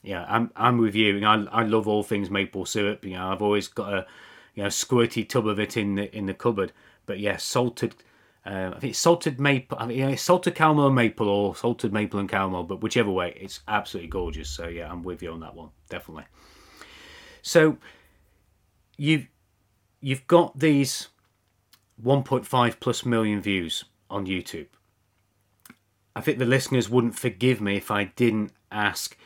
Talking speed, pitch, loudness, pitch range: 180 wpm, 105 Hz, -25 LUFS, 95-125 Hz